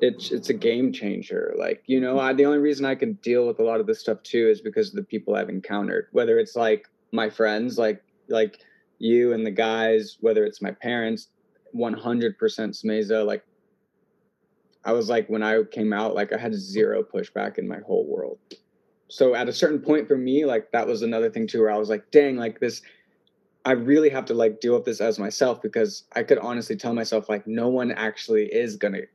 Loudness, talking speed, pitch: -24 LUFS, 220 wpm, 135 Hz